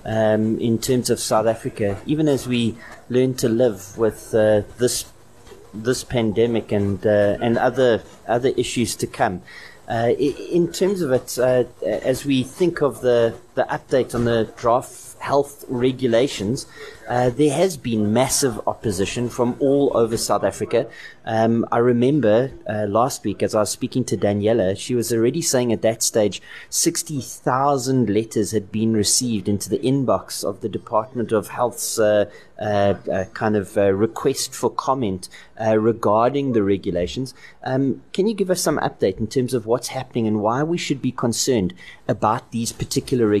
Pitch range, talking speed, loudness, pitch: 110-130 Hz, 165 wpm, -21 LUFS, 120 Hz